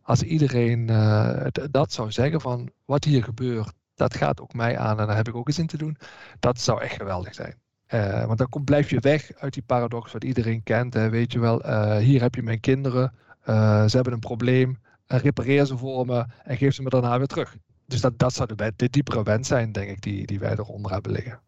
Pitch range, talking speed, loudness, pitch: 110-130 Hz, 245 wpm, -24 LUFS, 120 Hz